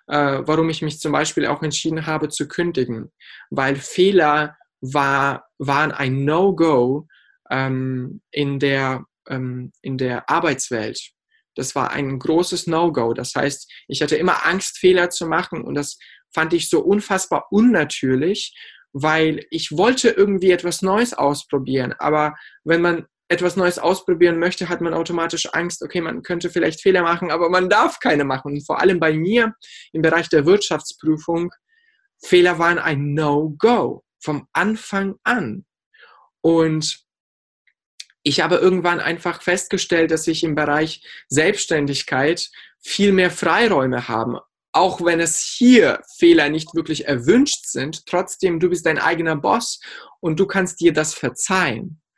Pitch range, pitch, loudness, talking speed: 145-180 Hz, 165 Hz, -19 LUFS, 145 wpm